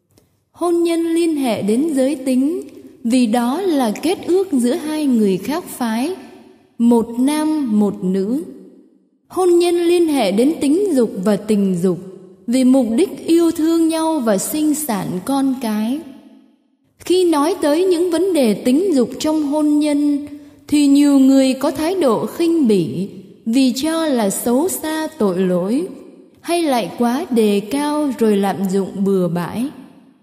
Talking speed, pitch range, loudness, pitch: 155 wpm, 225-315 Hz, -17 LUFS, 270 Hz